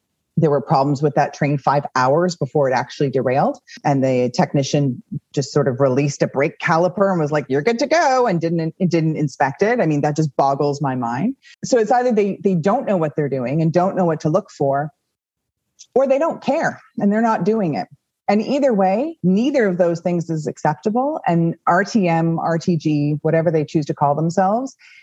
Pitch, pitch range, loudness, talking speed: 165 Hz, 145-200 Hz, -19 LUFS, 205 wpm